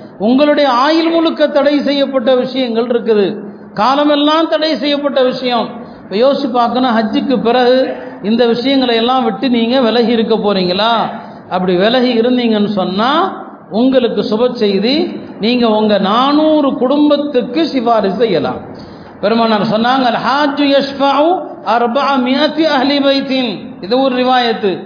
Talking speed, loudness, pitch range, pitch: 115 wpm, -12 LUFS, 225-275 Hz, 250 Hz